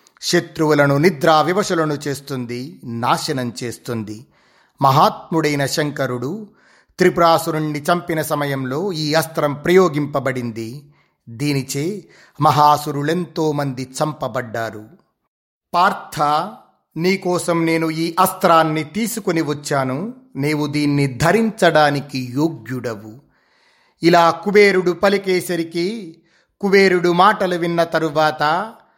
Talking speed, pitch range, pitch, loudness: 75 wpm, 140-175 Hz, 155 Hz, -18 LUFS